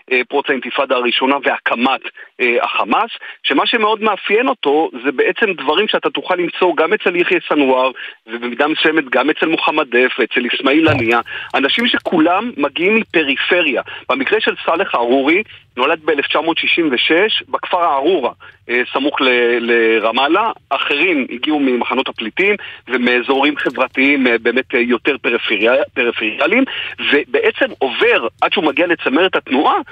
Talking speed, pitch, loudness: 125 wpm, 140 Hz, -15 LUFS